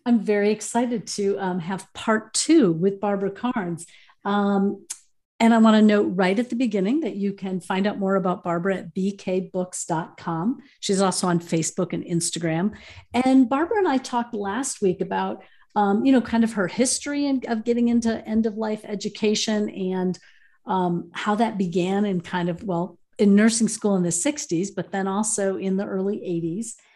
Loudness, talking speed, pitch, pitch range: -23 LUFS, 185 wpm, 200 Hz, 185-225 Hz